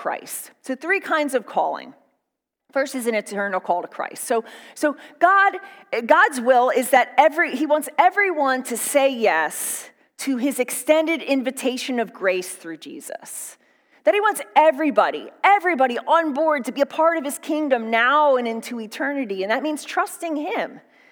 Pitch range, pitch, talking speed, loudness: 245-315 Hz, 275 Hz, 165 wpm, -20 LUFS